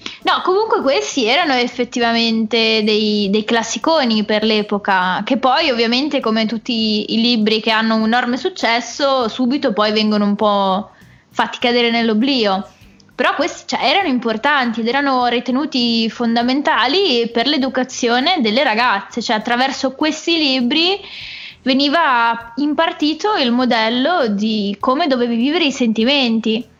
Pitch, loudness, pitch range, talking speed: 240 Hz, -16 LUFS, 225-270 Hz, 130 wpm